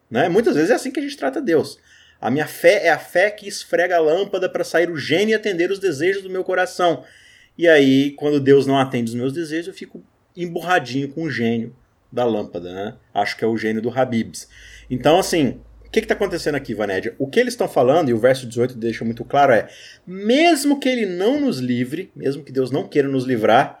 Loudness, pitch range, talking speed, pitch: -19 LUFS, 125-190 Hz, 230 wpm, 150 Hz